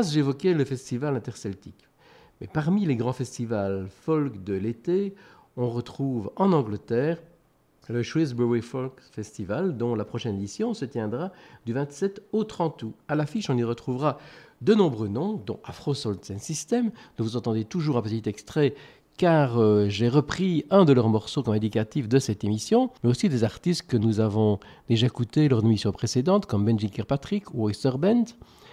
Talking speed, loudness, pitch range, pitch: 170 wpm, -26 LUFS, 110-160 Hz, 130 Hz